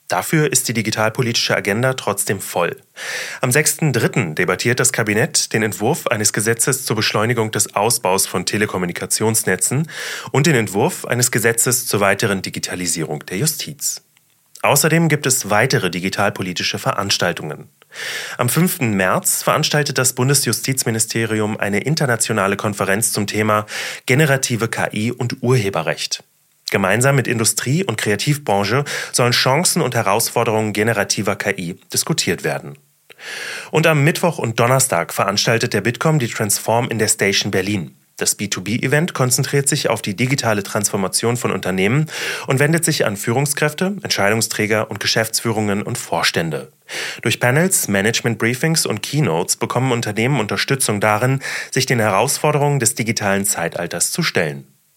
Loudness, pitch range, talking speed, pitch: -17 LUFS, 105-135 Hz, 130 wpm, 115 Hz